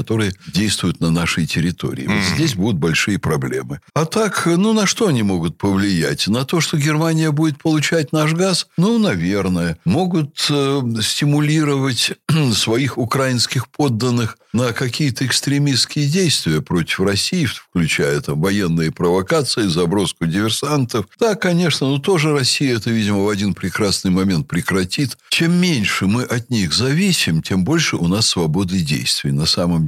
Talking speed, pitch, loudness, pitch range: 145 wpm, 130 Hz, -17 LUFS, 100-155 Hz